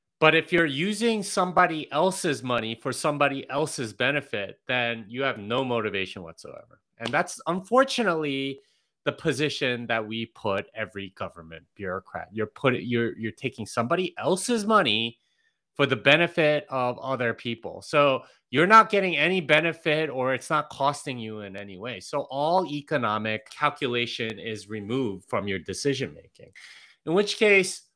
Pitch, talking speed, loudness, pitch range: 135 Hz, 150 wpm, -25 LUFS, 115-165 Hz